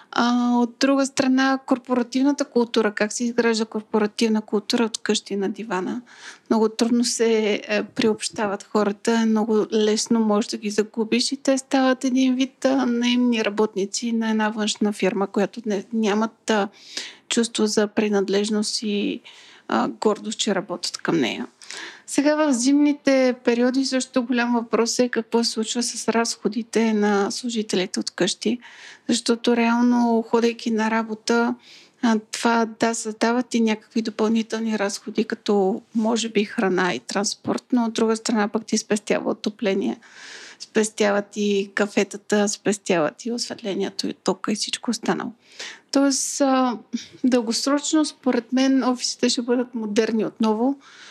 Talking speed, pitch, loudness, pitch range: 130 wpm, 225 Hz, -22 LUFS, 210-245 Hz